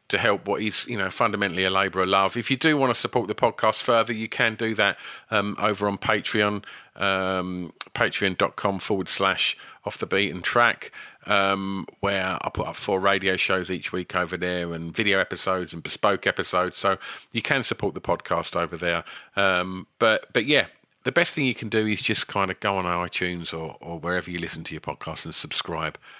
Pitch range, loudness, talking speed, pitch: 90-105 Hz, -24 LUFS, 205 wpm, 95 Hz